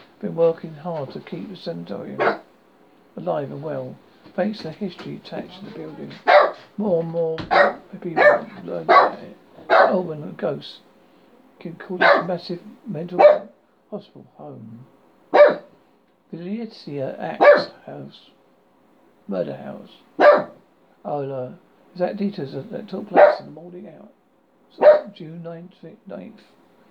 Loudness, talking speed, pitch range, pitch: -19 LUFS, 125 wpm, 160-200 Hz, 175 Hz